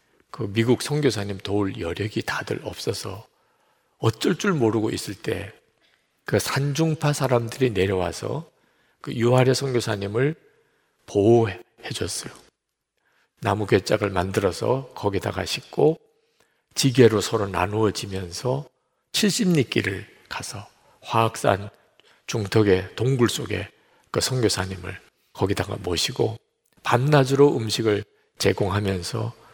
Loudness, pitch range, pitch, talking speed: -23 LUFS, 100-135 Hz, 115 Hz, 240 characters per minute